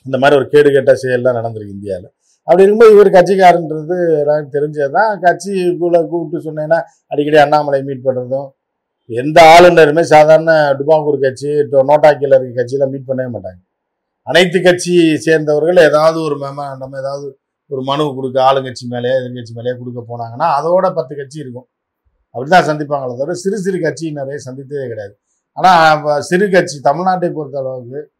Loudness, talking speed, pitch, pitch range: -11 LUFS, 145 wpm, 145 Hz, 135-165 Hz